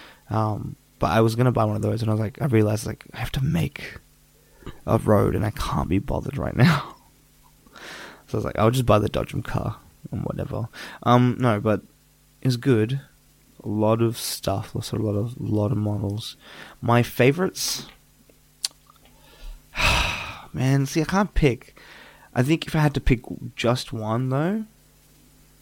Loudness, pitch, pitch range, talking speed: -24 LUFS, 115 Hz, 105-135 Hz, 170 wpm